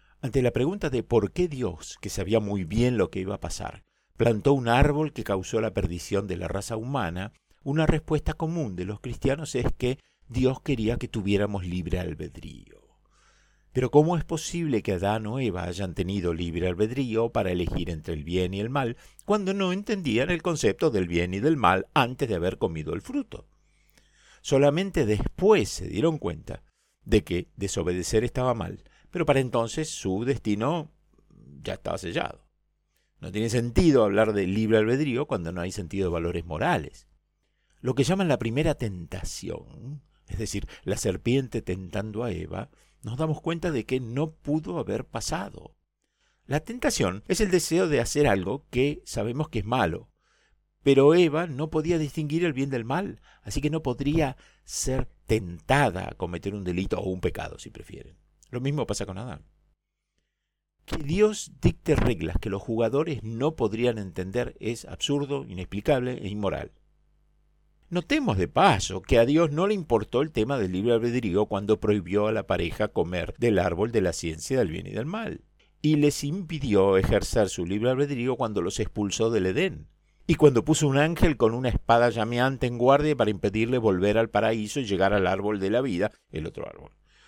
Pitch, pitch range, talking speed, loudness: 115 Hz, 100-145 Hz, 175 wpm, -26 LUFS